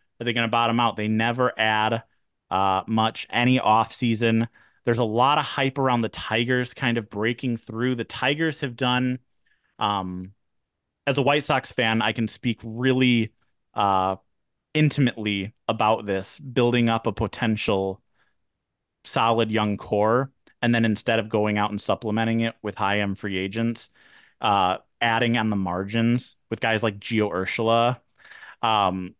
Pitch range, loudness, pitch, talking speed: 105-120 Hz, -24 LUFS, 115 Hz, 155 wpm